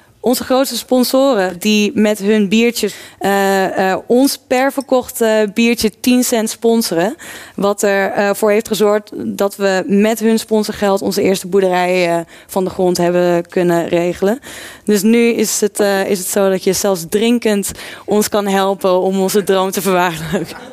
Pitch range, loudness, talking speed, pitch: 190-225 Hz, -14 LUFS, 160 wpm, 205 Hz